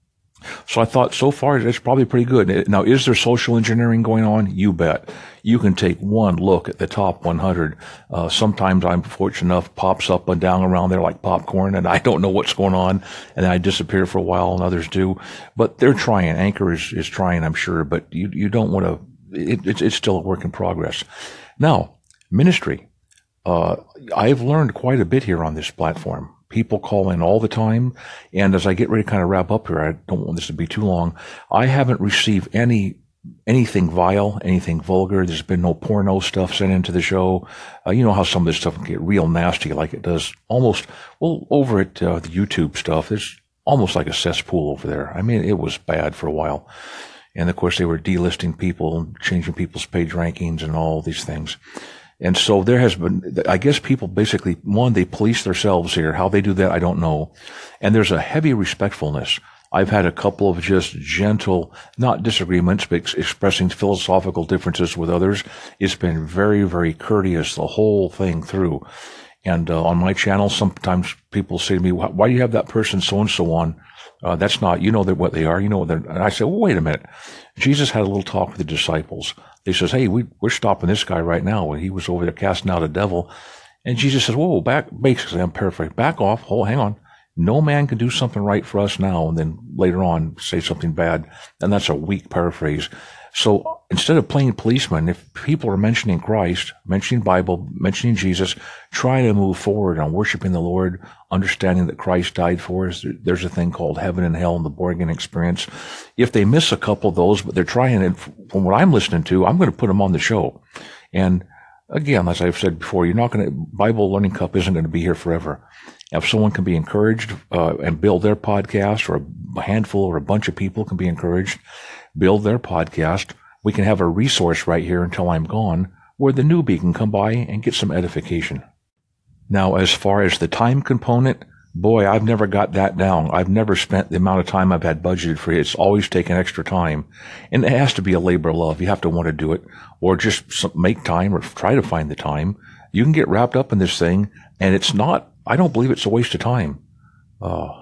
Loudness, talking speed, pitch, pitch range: -19 LUFS, 220 wpm, 95 Hz, 85-105 Hz